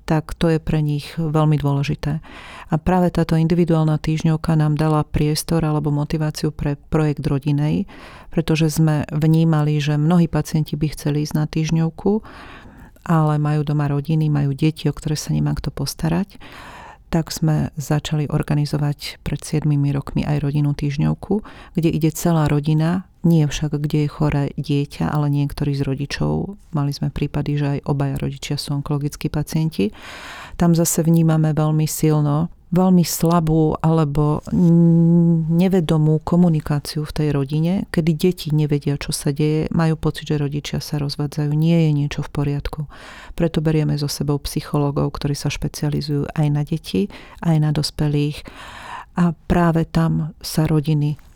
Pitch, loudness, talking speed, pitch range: 155 Hz, -20 LUFS, 145 wpm, 145-160 Hz